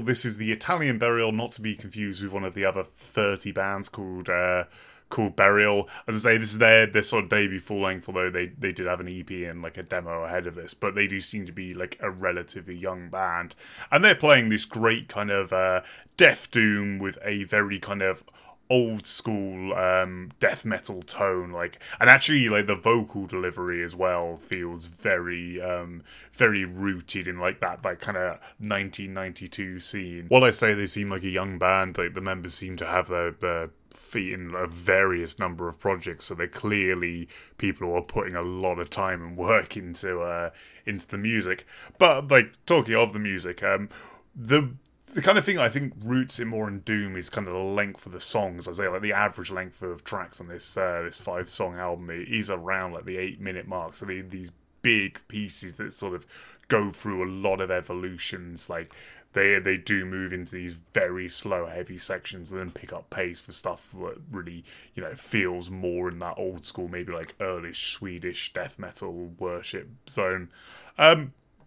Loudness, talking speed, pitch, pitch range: -25 LUFS, 205 wpm, 95 Hz, 90-105 Hz